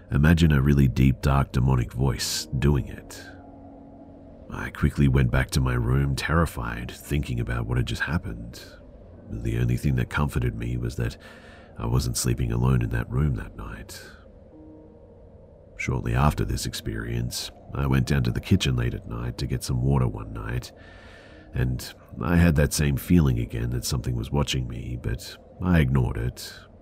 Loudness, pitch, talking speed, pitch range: -25 LUFS, 70 Hz, 170 wpm, 60-85 Hz